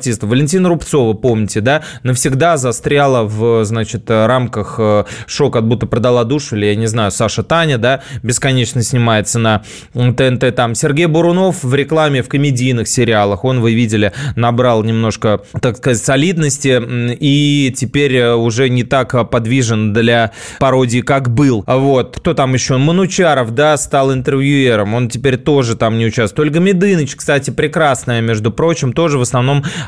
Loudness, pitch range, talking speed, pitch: -13 LUFS, 115-140 Hz, 150 wpm, 125 Hz